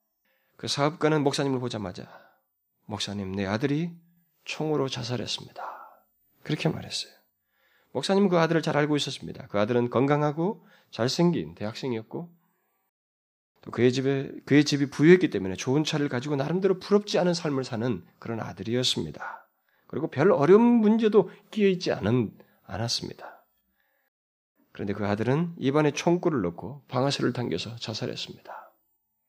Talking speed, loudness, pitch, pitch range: 335 characters per minute, -26 LUFS, 140 Hz, 115-170 Hz